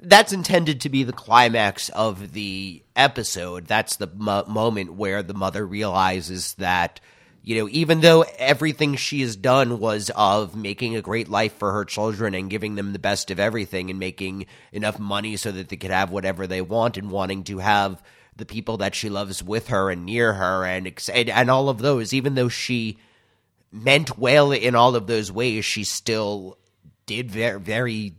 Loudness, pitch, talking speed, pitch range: -22 LUFS, 110 Hz, 190 wpm, 100-120 Hz